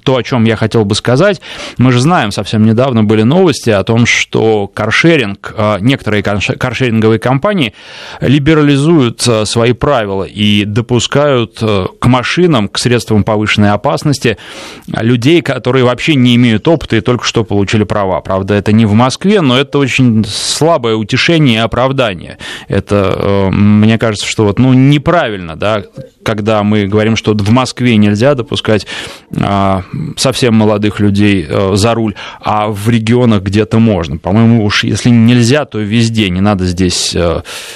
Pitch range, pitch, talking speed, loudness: 105-130 Hz, 115 Hz, 145 wpm, -10 LUFS